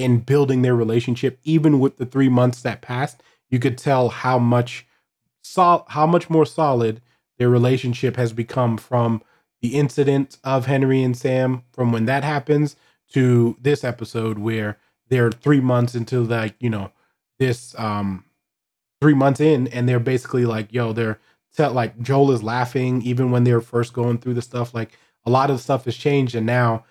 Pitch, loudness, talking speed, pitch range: 125 Hz, -20 LUFS, 180 wpm, 120-135 Hz